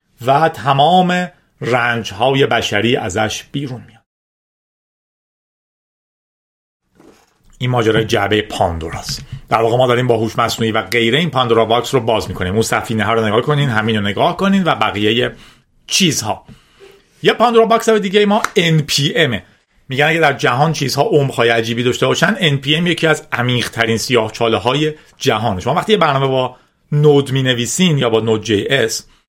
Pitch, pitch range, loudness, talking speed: 125 Hz, 115-155 Hz, -15 LUFS, 160 wpm